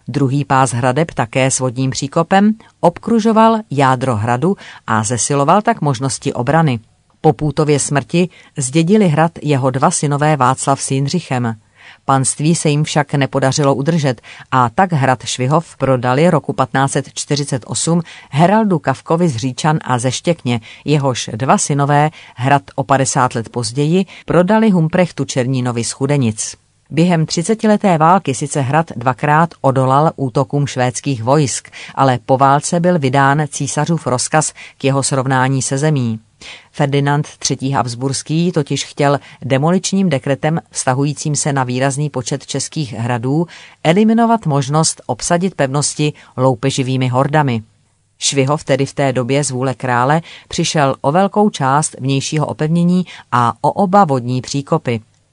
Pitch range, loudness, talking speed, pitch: 130-160 Hz, -15 LUFS, 130 wpm, 140 Hz